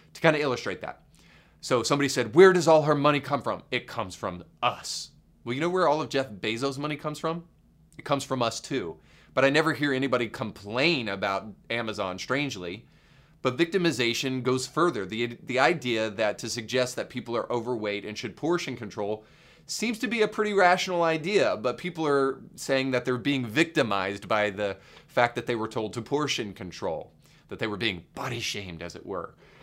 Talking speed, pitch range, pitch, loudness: 195 wpm, 110-155 Hz, 130 Hz, -27 LUFS